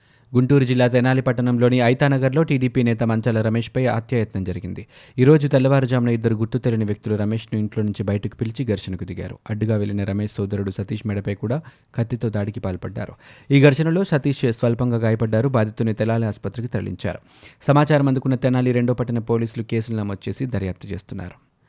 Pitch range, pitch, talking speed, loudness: 105-130 Hz, 115 Hz, 150 wpm, -21 LUFS